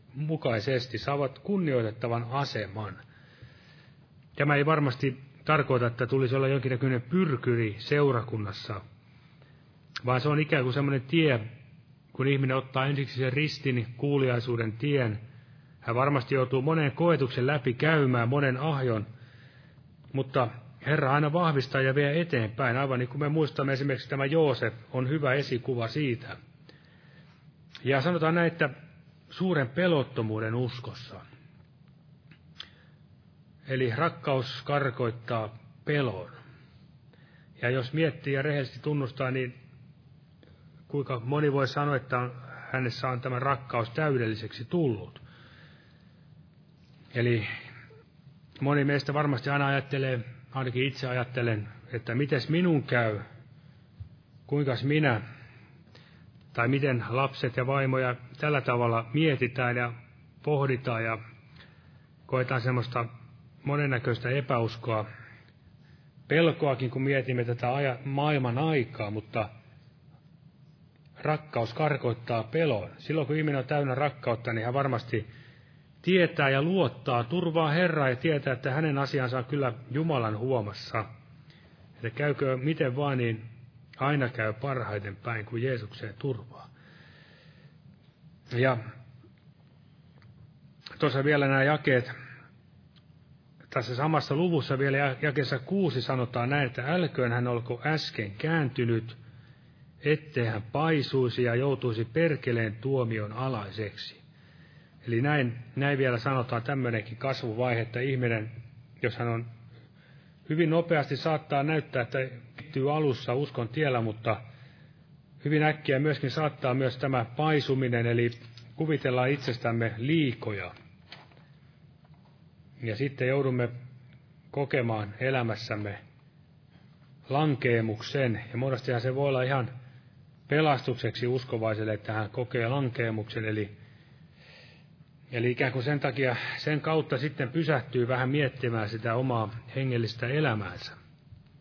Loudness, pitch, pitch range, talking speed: -29 LUFS, 135 Hz, 120-150 Hz, 105 wpm